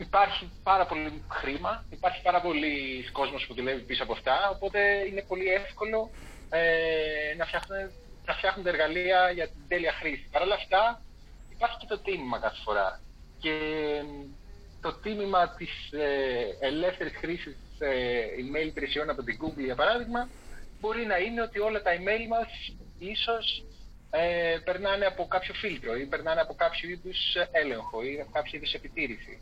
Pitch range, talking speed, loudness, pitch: 150-200 Hz, 160 wpm, -29 LUFS, 175 Hz